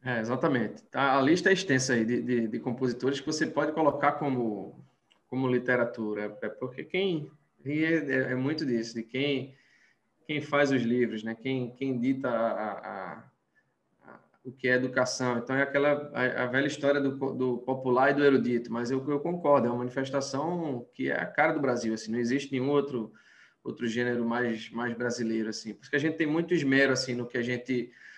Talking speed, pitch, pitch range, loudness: 195 wpm, 130 Hz, 120-140 Hz, -29 LUFS